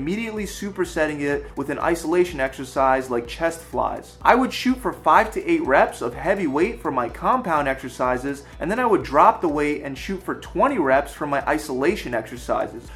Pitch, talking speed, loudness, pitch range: 150 Hz, 195 wpm, -22 LUFS, 135-180 Hz